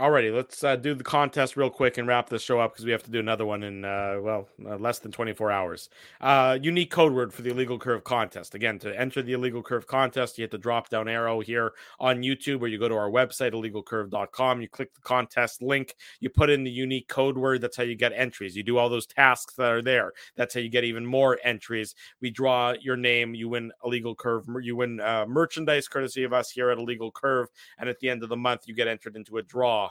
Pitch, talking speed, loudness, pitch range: 120 Hz, 250 wpm, -26 LUFS, 115-130 Hz